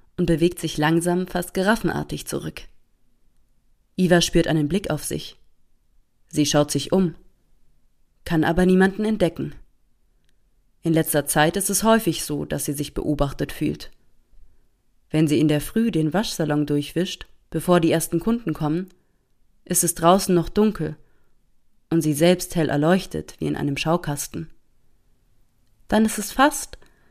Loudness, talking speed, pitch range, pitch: -22 LUFS, 140 wpm, 145-180 Hz, 165 Hz